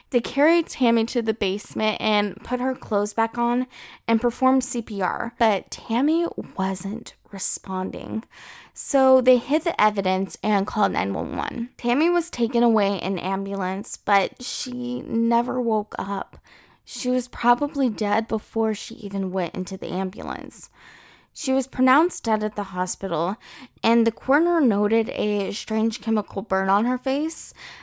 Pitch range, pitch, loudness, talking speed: 200-250 Hz, 225 Hz, -23 LUFS, 145 wpm